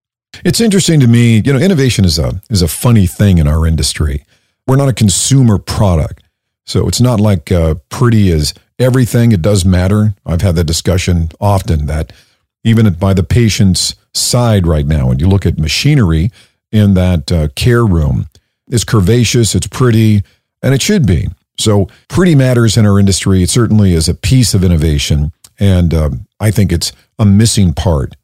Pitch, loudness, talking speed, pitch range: 100 Hz, -11 LUFS, 180 wpm, 85-115 Hz